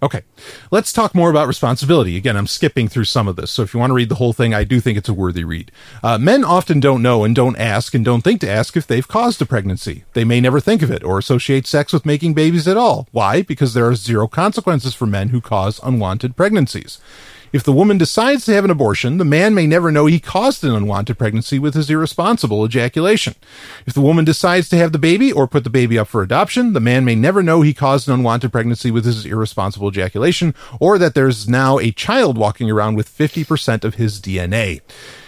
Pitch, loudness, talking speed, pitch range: 130 Hz, -15 LUFS, 235 wpm, 115-160 Hz